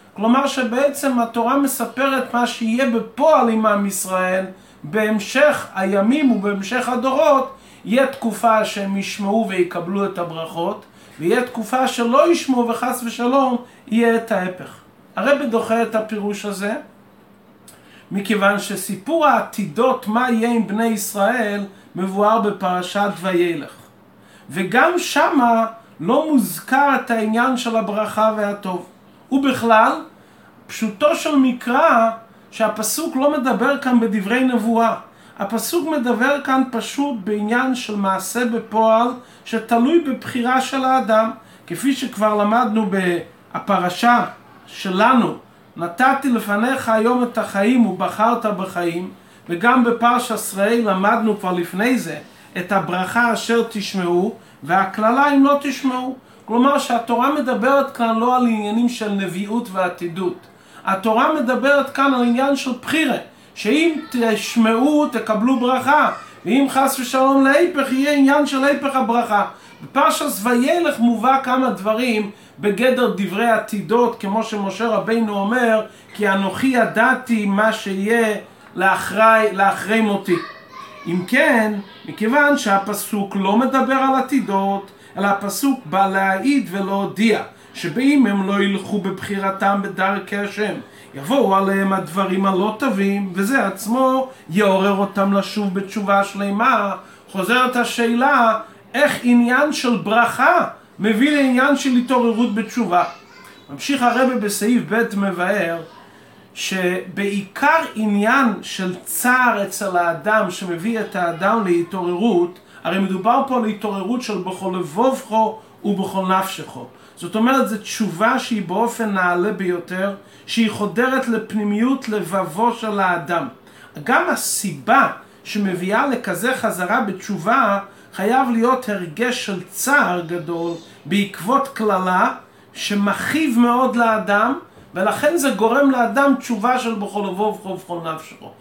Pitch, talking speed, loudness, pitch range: 225 Hz, 115 wpm, -18 LUFS, 200-255 Hz